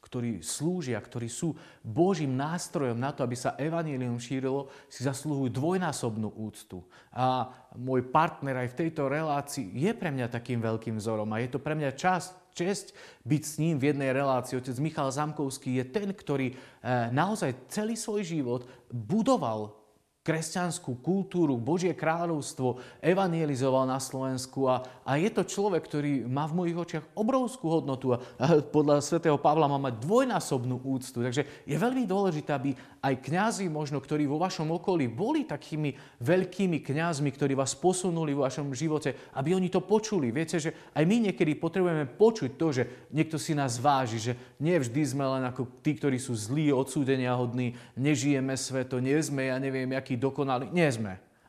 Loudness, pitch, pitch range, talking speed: -30 LUFS, 140 Hz, 130-165 Hz, 165 wpm